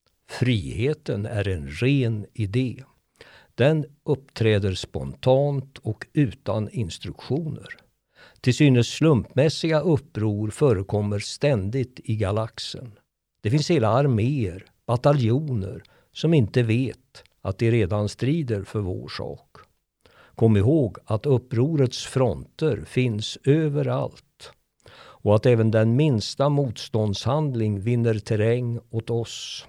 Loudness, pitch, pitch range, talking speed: -23 LUFS, 120 Hz, 105-135 Hz, 105 wpm